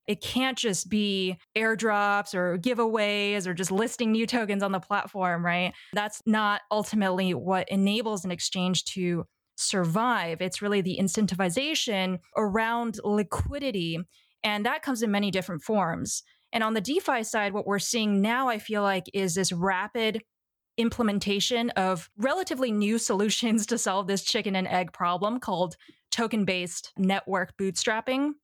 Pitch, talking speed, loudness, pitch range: 205 Hz, 150 wpm, -27 LUFS, 190-225 Hz